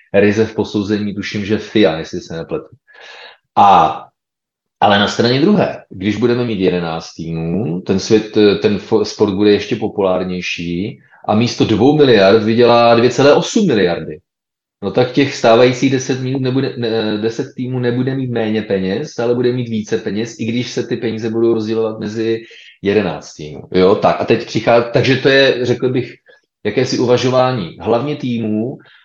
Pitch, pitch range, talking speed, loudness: 115 Hz, 105-125 Hz, 155 wpm, -15 LUFS